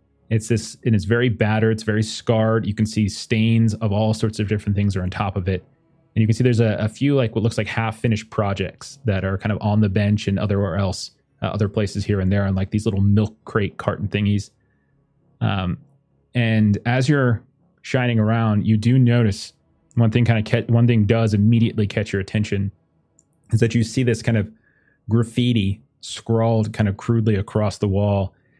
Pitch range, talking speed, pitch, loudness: 105-115 Hz, 210 wpm, 110 Hz, -20 LUFS